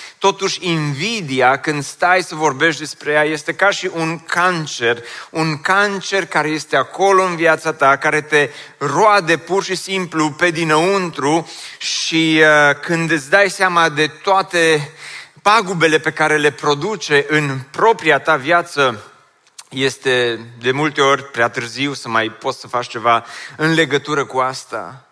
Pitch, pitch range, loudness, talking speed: 155 Hz, 140-170 Hz, -16 LUFS, 150 wpm